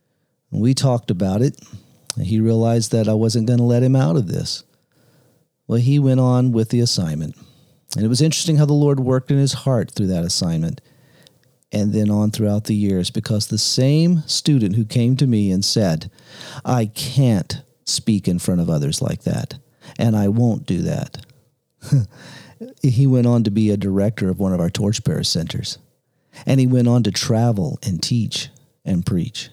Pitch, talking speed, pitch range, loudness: 125 Hz, 185 wpm, 110-140 Hz, -18 LUFS